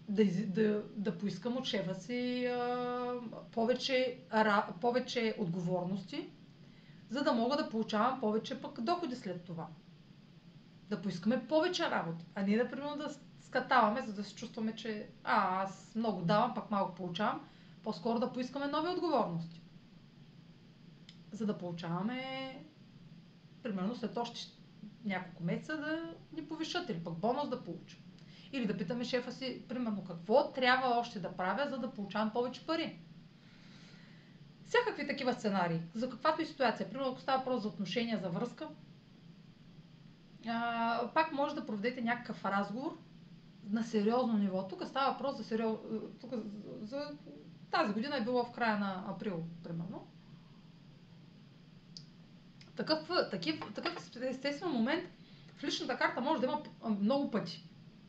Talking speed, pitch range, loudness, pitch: 135 wpm, 180-250 Hz, -36 LUFS, 215 Hz